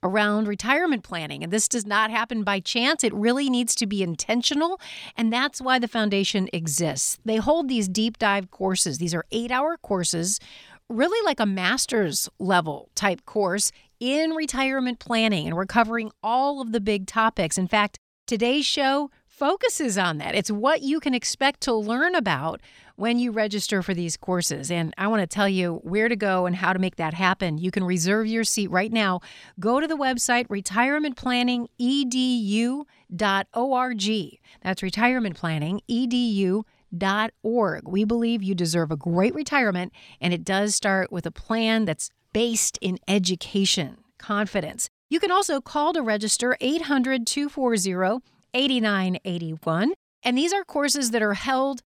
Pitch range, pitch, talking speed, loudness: 190-255 Hz, 220 Hz, 155 wpm, -24 LUFS